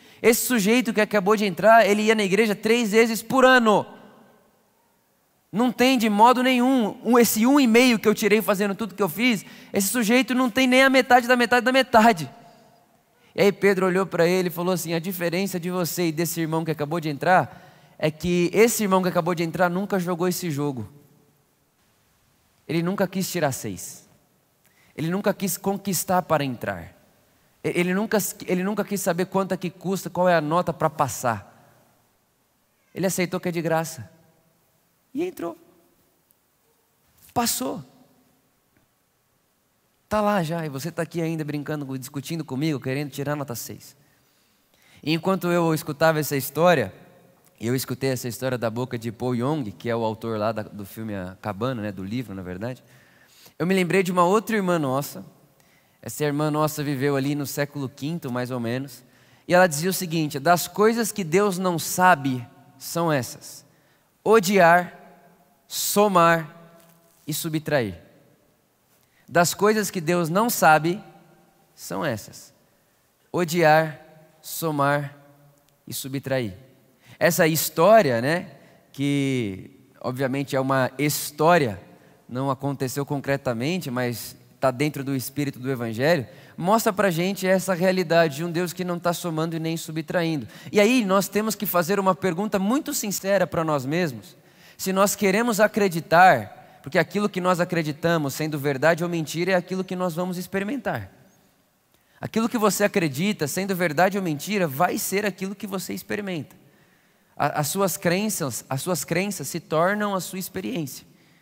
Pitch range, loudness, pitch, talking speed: 145-195 Hz, -23 LUFS, 170 Hz, 155 wpm